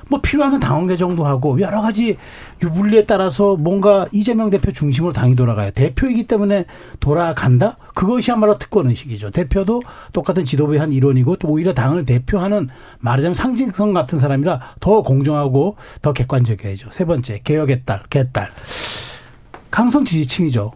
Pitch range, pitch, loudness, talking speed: 135-205 Hz, 170 Hz, -17 LUFS, 375 characters per minute